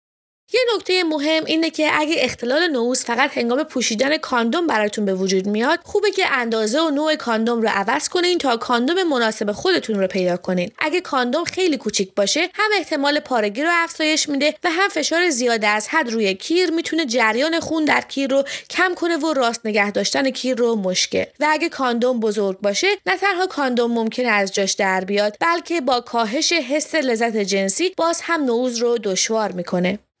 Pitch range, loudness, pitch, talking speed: 220-325 Hz, -19 LUFS, 265 Hz, 180 wpm